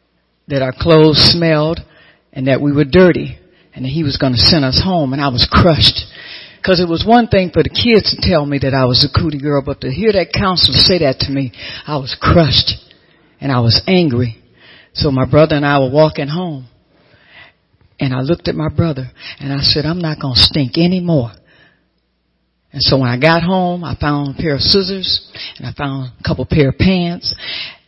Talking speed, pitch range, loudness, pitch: 210 wpm, 130-165 Hz, -13 LUFS, 145 Hz